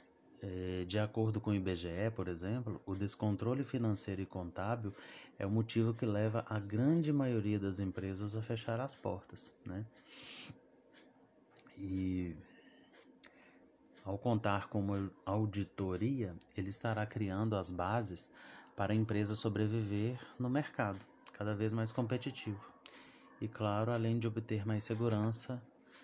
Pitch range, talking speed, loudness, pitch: 100-115 Hz, 130 wpm, -38 LUFS, 105 Hz